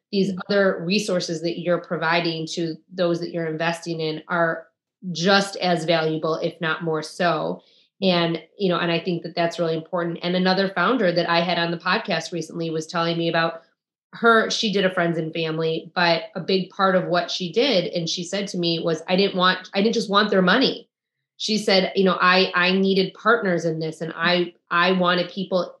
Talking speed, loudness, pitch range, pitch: 205 wpm, -22 LUFS, 165-190 Hz, 175 Hz